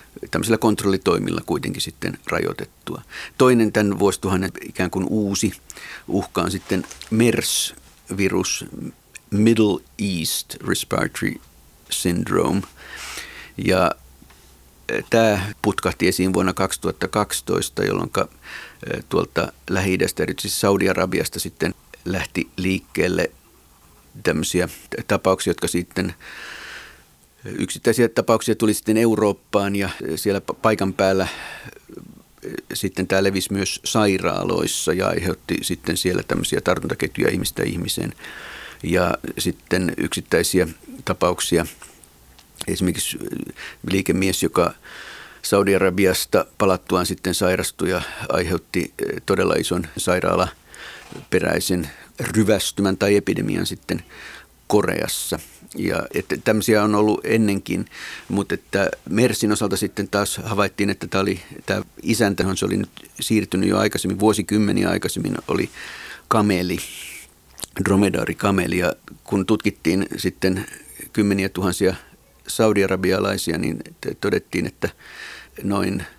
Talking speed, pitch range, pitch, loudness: 95 wpm, 90-105 Hz, 95 Hz, -21 LUFS